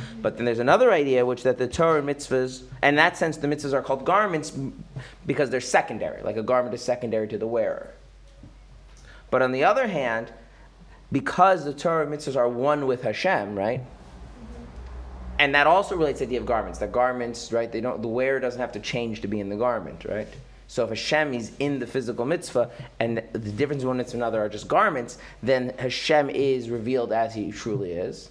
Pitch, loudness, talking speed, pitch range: 125 Hz, -24 LUFS, 205 wpm, 115-140 Hz